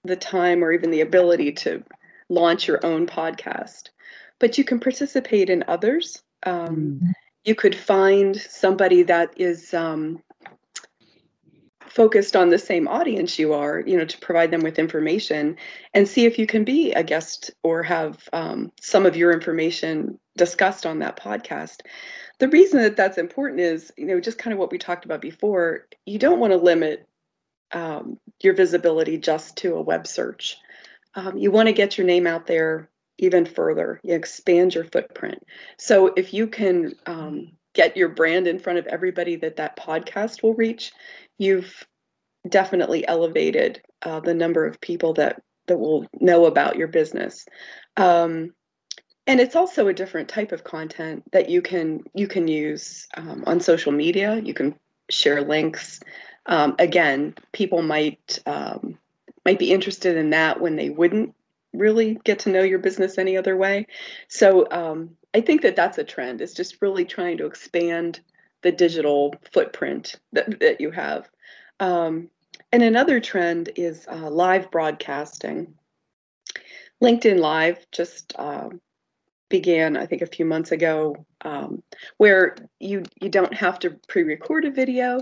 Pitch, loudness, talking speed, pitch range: 180 Hz, -21 LUFS, 160 wpm, 165-215 Hz